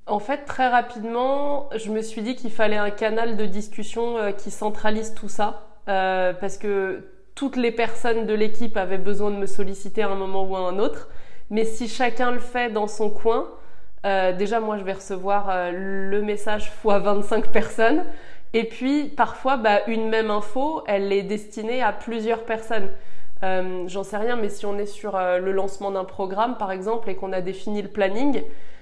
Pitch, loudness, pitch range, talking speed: 210 Hz, -25 LUFS, 200-230 Hz, 195 wpm